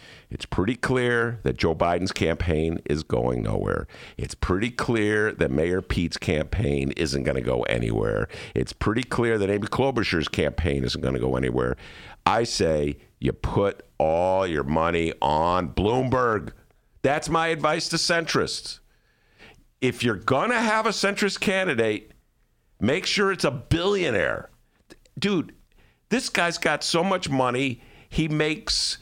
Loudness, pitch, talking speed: -24 LUFS, 120 Hz, 145 wpm